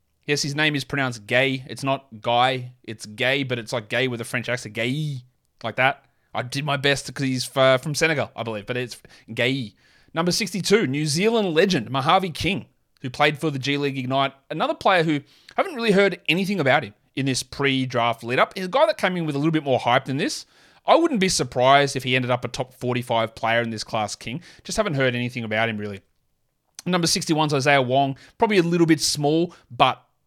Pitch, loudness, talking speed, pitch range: 135 Hz, -22 LUFS, 220 wpm, 125-155 Hz